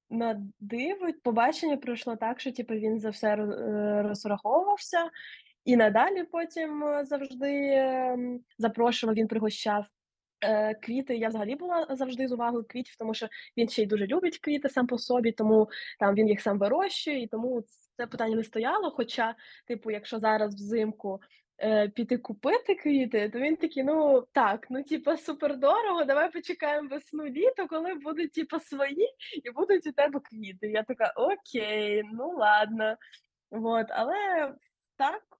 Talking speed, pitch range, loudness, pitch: 145 wpm, 220-300 Hz, -29 LUFS, 245 Hz